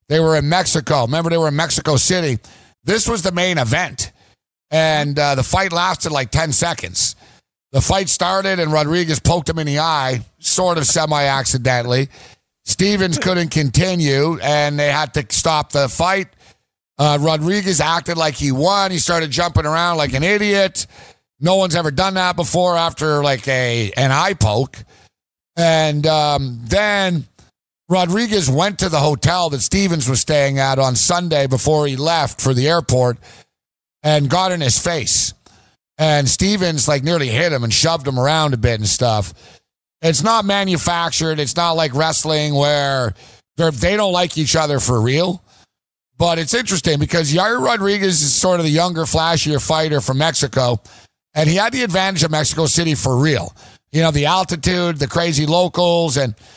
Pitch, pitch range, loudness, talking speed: 155 Hz, 135-175 Hz, -16 LUFS, 170 wpm